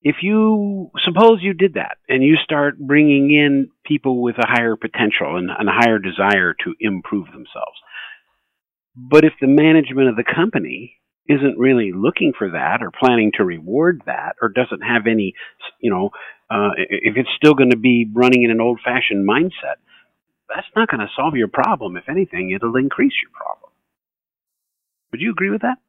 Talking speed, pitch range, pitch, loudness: 180 wpm, 120-165 Hz, 135 Hz, -16 LUFS